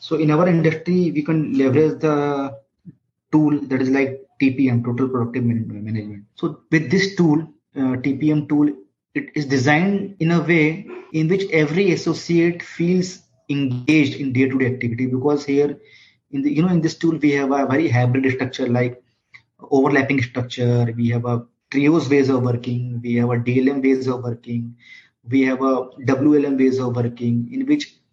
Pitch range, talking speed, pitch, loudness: 125-155 Hz, 170 wpm, 135 Hz, -19 LUFS